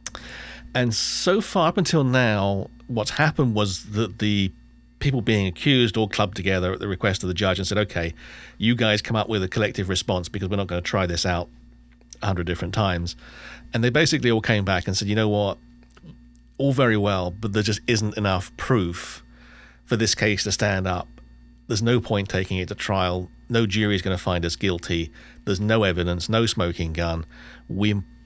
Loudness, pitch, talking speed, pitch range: -23 LUFS, 100 Hz, 195 wpm, 90-110 Hz